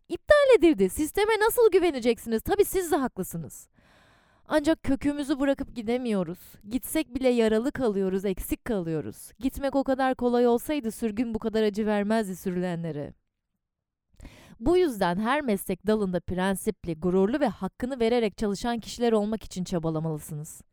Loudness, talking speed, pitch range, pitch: -26 LUFS, 130 wpm, 190-275 Hz, 230 Hz